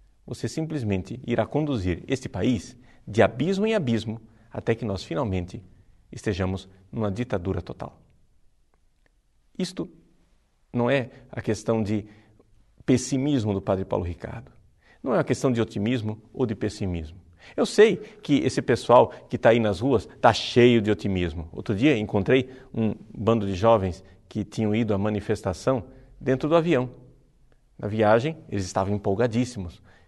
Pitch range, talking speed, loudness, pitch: 100-130 Hz, 145 wpm, -25 LUFS, 110 Hz